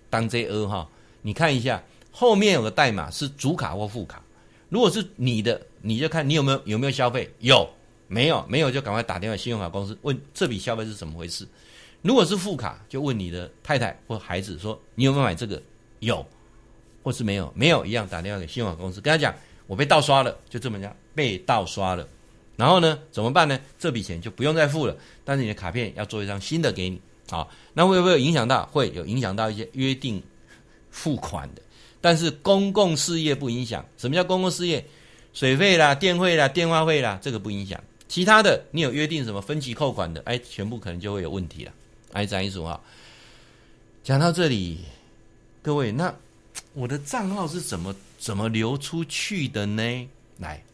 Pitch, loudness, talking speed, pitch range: 120 Hz, -24 LUFS, 300 characters per minute, 100-150 Hz